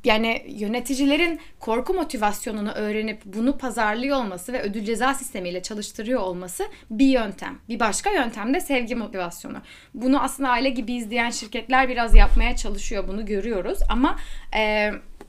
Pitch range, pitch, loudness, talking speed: 210-260 Hz, 235 Hz, -24 LUFS, 135 wpm